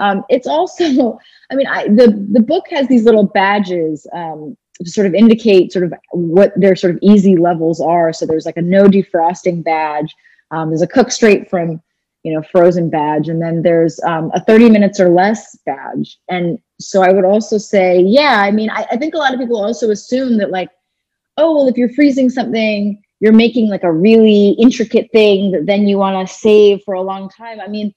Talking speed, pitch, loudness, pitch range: 210 wpm, 200 Hz, -12 LUFS, 175-225 Hz